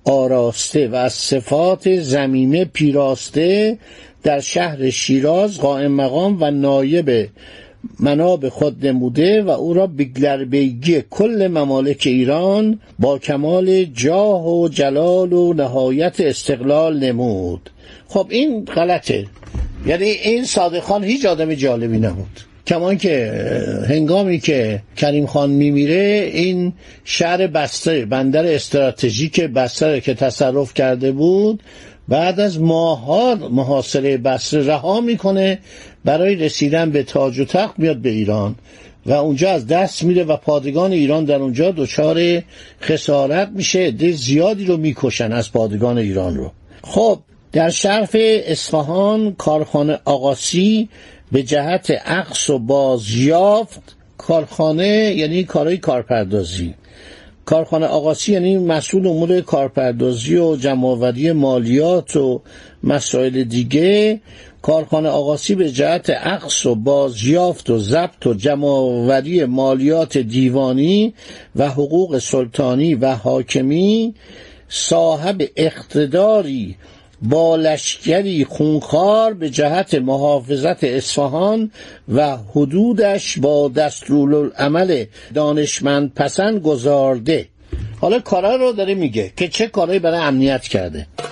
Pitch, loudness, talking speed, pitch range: 150 Hz, -16 LUFS, 110 wpm, 135-180 Hz